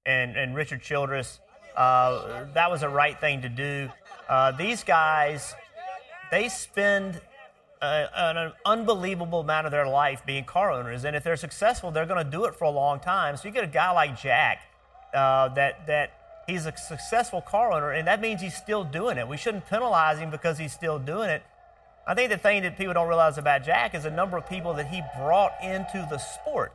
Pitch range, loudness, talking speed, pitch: 145-190 Hz, -26 LUFS, 205 wpm, 160 Hz